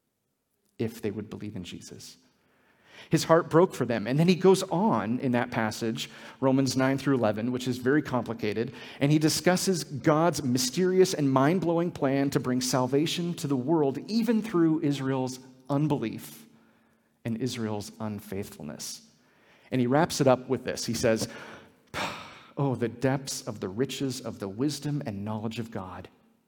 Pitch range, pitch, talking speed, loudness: 115-155 Hz, 135 Hz, 160 wpm, -27 LUFS